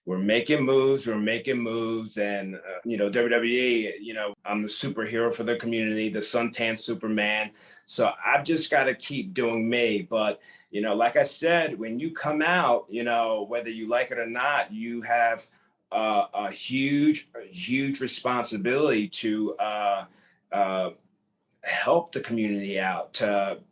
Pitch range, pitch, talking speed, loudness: 105-125 Hz, 115 Hz, 160 wpm, -26 LUFS